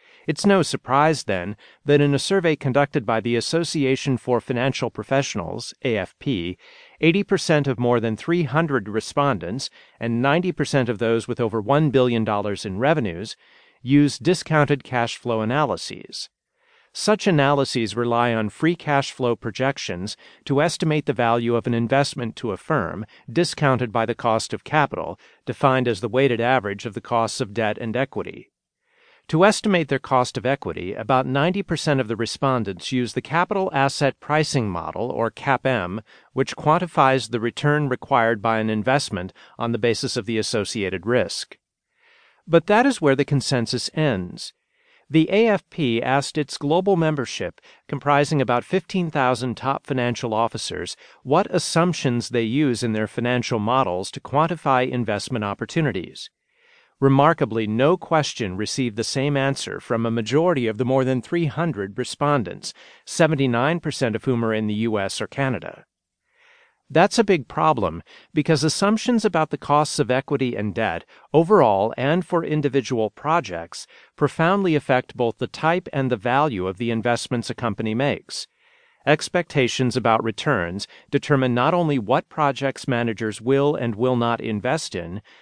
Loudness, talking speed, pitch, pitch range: -22 LUFS, 150 wpm, 135 Hz, 115-155 Hz